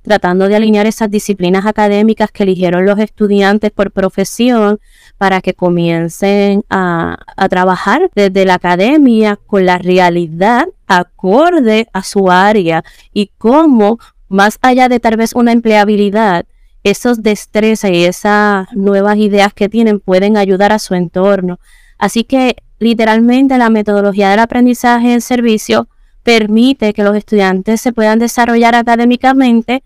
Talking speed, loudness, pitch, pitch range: 135 wpm, -10 LUFS, 210 Hz, 195-230 Hz